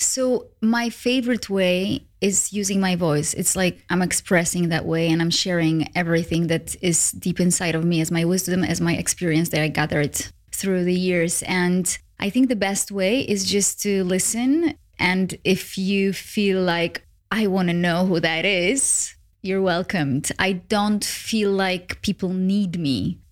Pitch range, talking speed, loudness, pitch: 170-200 Hz, 170 wpm, -21 LUFS, 185 Hz